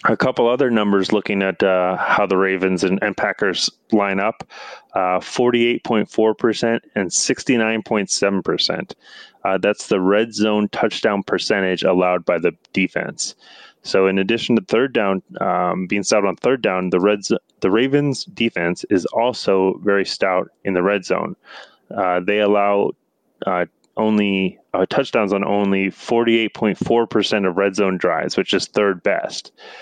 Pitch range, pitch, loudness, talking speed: 95-110 Hz, 100 Hz, -19 LUFS, 145 wpm